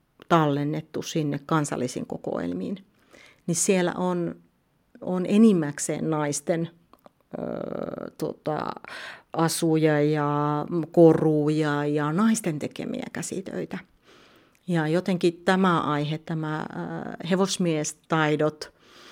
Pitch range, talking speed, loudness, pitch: 150-175 Hz, 80 wpm, -25 LUFS, 160 Hz